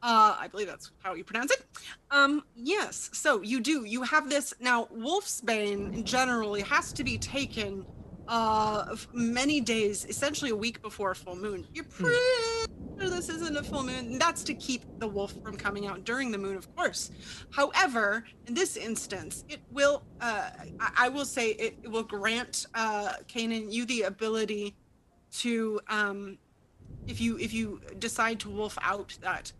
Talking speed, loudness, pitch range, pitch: 175 wpm, -30 LUFS, 210-275 Hz, 225 Hz